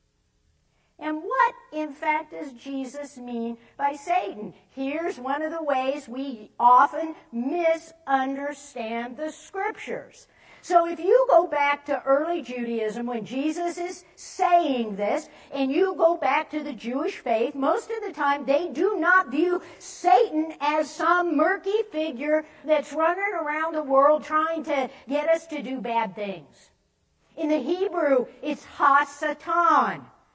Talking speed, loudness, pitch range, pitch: 140 wpm, -25 LUFS, 275-335 Hz, 305 Hz